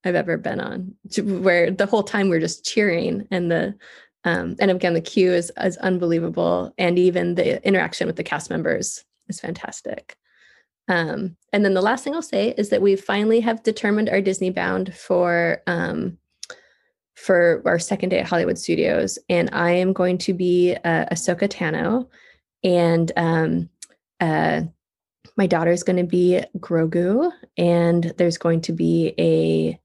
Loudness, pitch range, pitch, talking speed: -21 LUFS, 170-200 Hz, 180 Hz, 165 wpm